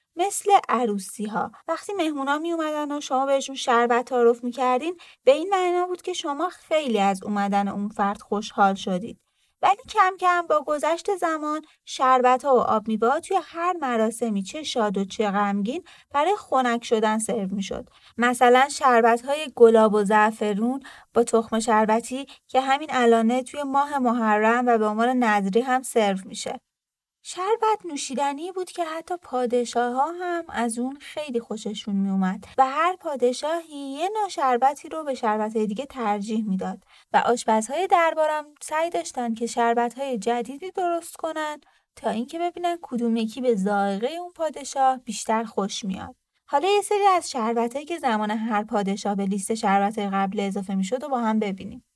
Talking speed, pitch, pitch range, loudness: 165 wpm, 250 Hz, 220-310 Hz, -23 LUFS